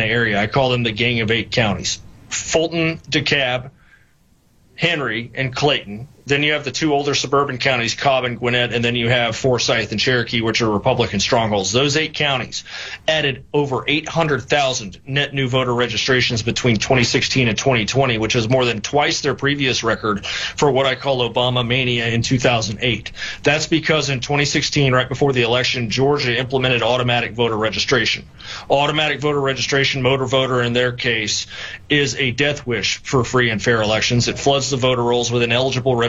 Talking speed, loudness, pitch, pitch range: 175 wpm, -18 LUFS, 125 Hz, 115-140 Hz